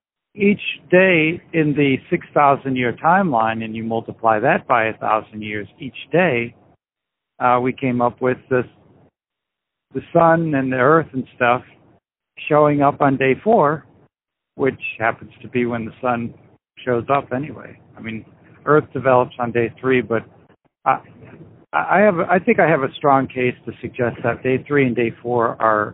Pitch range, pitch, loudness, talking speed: 115-145 Hz, 125 Hz, -18 LUFS, 165 wpm